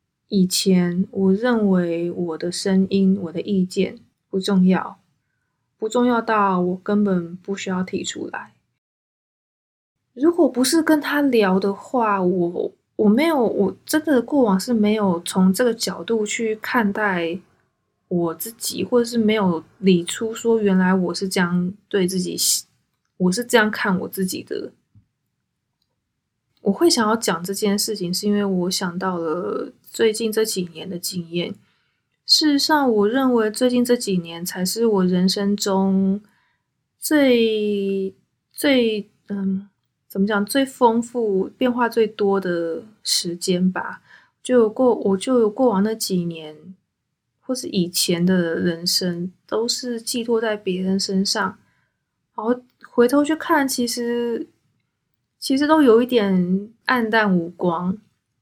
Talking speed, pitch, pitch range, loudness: 195 characters per minute, 200 Hz, 185-235 Hz, -20 LUFS